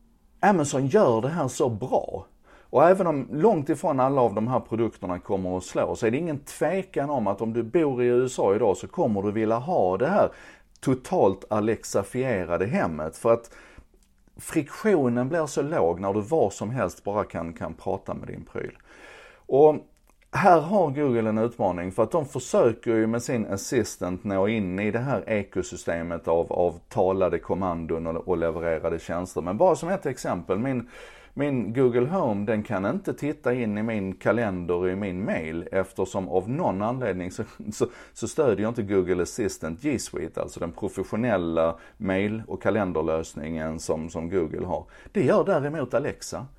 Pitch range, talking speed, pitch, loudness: 90-125 Hz, 175 wpm, 110 Hz, -25 LUFS